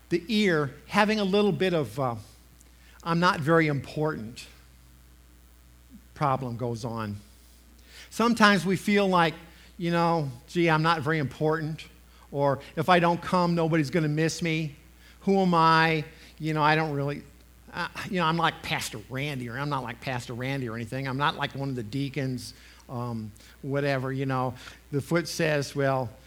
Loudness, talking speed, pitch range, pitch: -26 LUFS, 170 wpm, 120-165 Hz, 140 Hz